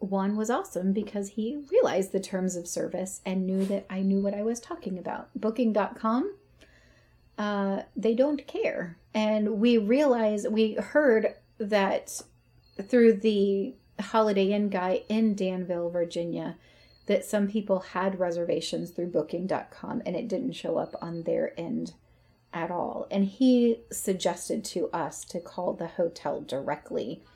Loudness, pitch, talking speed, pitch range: -28 LUFS, 205 Hz, 145 wpm, 185-225 Hz